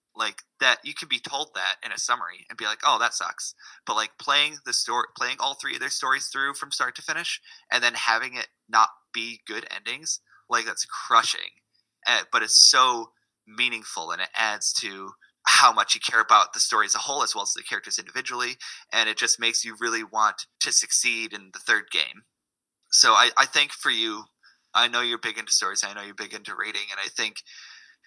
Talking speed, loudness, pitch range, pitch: 215 wpm, -23 LUFS, 115-135 Hz, 115 Hz